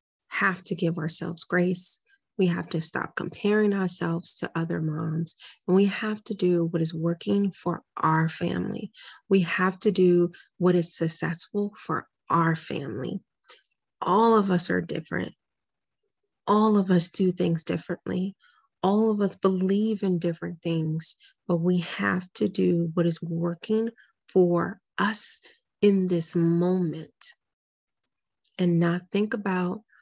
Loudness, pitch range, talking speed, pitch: -26 LUFS, 170-200 Hz, 140 wpm, 180 Hz